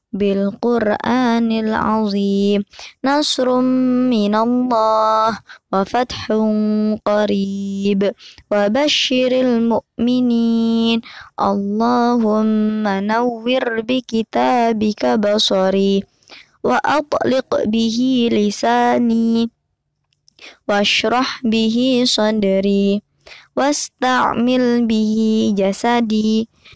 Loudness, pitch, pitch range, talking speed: -17 LUFS, 225 Hz, 210-245 Hz, 65 wpm